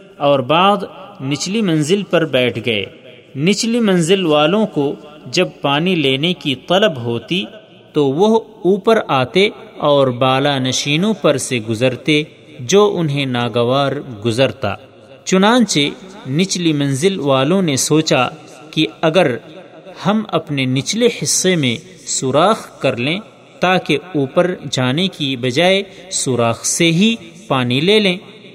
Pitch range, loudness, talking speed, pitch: 135-190 Hz, -16 LUFS, 120 wpm, 155 Hz